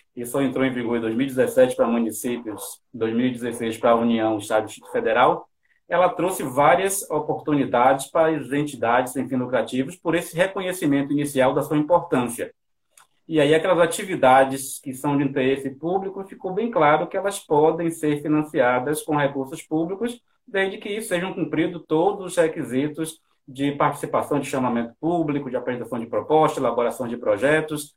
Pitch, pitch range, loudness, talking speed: 150 Hz, 130-175 Hz, -22 LUFS, 160 wpm